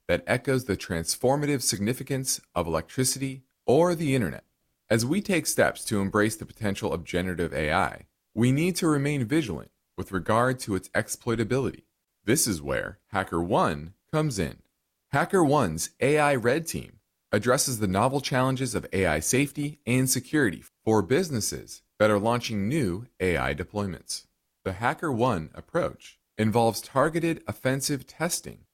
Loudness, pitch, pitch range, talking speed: -26 LUFS, 120 Hz, 100-135 Hz, 135 wpm